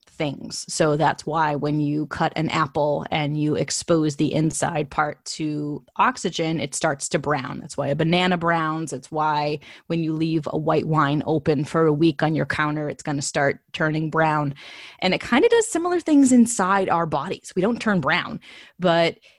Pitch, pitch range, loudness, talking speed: 155 Hz, 150-170 Hz, -22 LUFS, 190 wpm